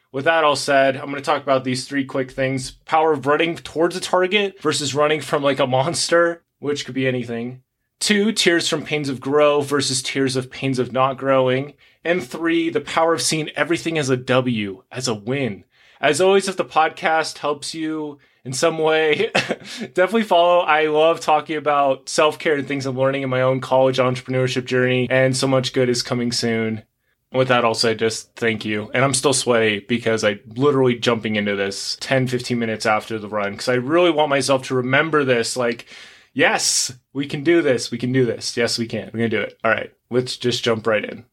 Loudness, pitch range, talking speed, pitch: -19 LUFS, 125-155 Hz, 210 wpm, 135 Hz